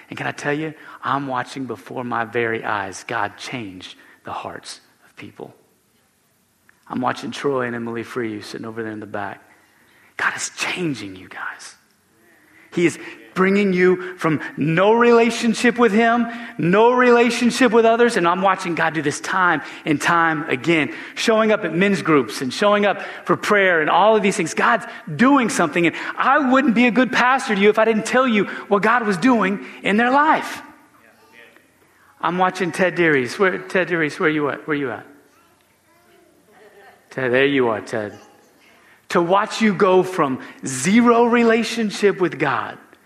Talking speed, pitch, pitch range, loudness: 175 wpm, 190 Hz, 150-230 Hz, -18 LUFS